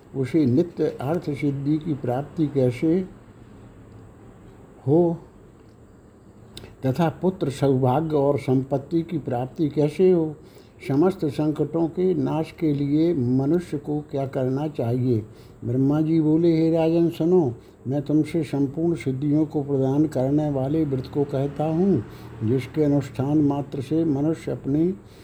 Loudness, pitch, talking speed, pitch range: -23 LUFS, 145 Hz, 115 wpm, 130-160 Hz